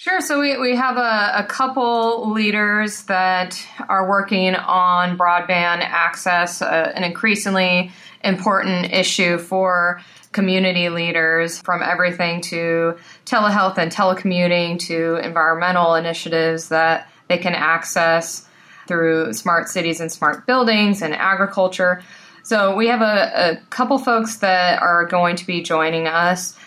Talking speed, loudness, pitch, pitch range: 130 wpm, -18 LUFS, 180 Hz, 170-200 Hz